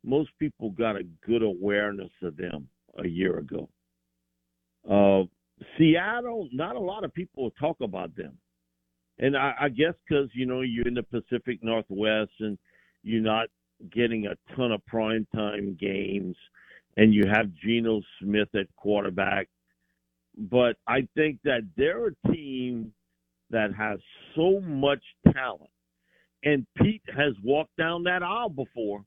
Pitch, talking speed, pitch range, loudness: 110 Hz, 145 wpm, 95-140 Hz, -27 LUFS